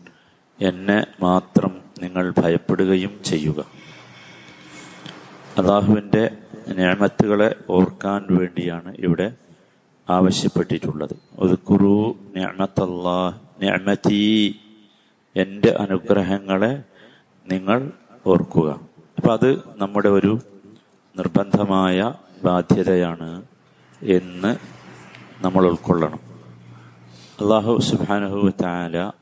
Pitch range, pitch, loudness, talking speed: 90-100 Hz, 95 Hz, -20 LUFS, 60 wpm